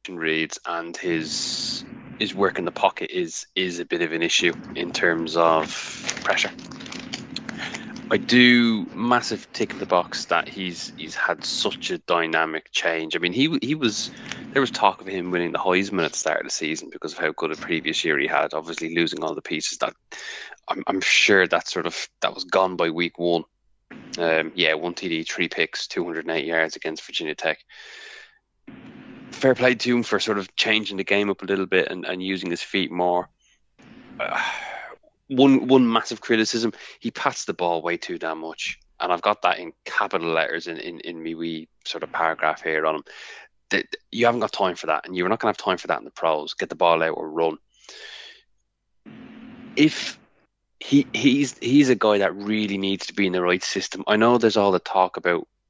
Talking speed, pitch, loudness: 205 wpm, 100 Hz, -23 LUFS